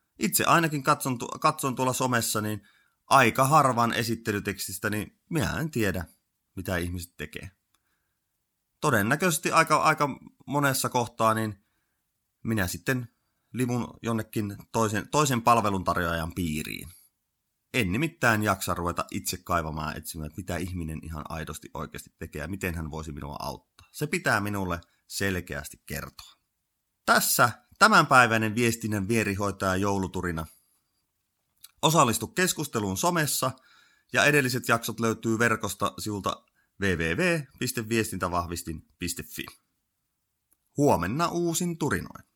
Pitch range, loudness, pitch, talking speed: 90-125 Hz, -26 LUFS, 110 Hz, 105 wpm